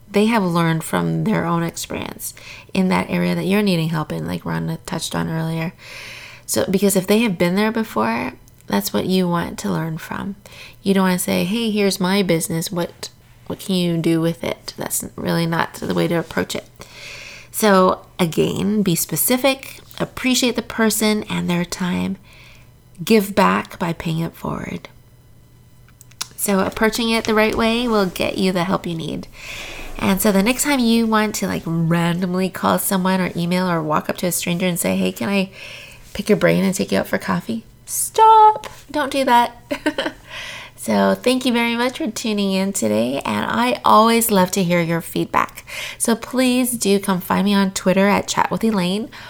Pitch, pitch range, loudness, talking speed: 185 Hz, 165-215 Hz, -19 LUFS, 185 wpm